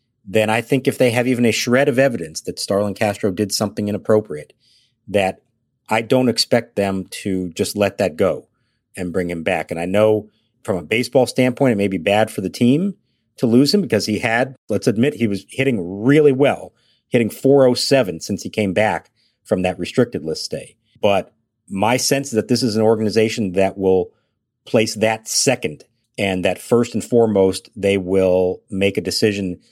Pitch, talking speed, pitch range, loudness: 110 Hz, 190 wpm, 100-125 Hz, -18 LUFS